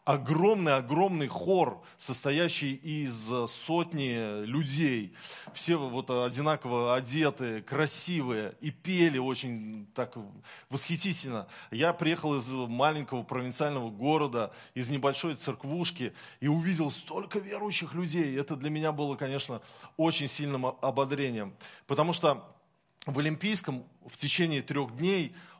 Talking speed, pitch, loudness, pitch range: 110 wpm, 145 Hz, -30 LUFS, 130-165 Hz